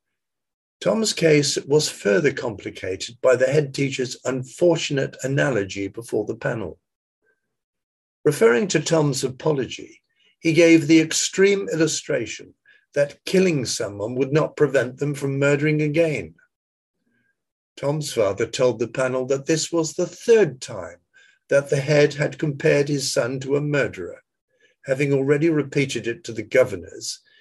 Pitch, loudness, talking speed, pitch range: 150 Hz, -21 LUFS, 135 wpm, 135-165 Hz